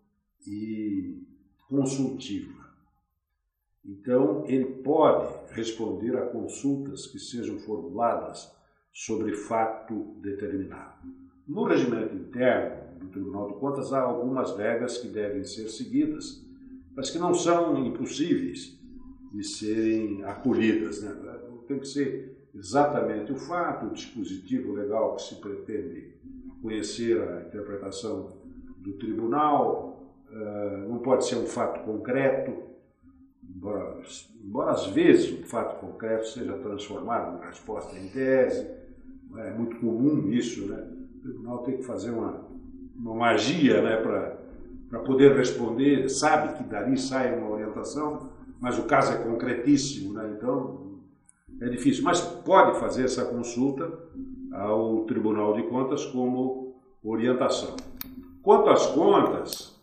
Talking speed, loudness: 120 wpm, -27 LUFS